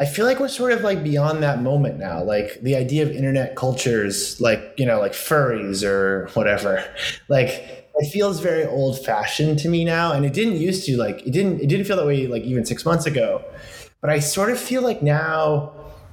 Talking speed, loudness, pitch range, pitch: 215 wpm, -21 LUFS, 130-180 Hz, 150 Hz